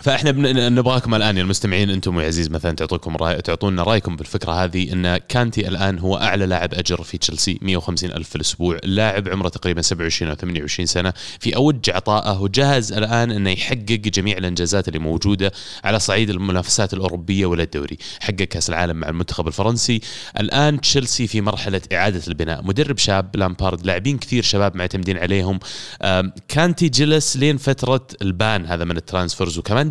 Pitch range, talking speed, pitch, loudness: 90-110 Hz, 165 wpm, 95 Hz, -19 LUFS